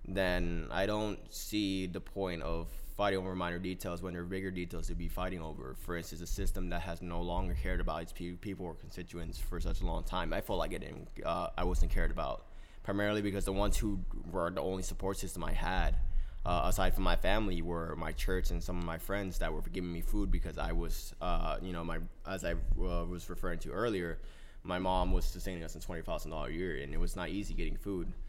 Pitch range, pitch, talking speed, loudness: 85-95 Hz, 90 Hz, 235 wpm, -38 LUFS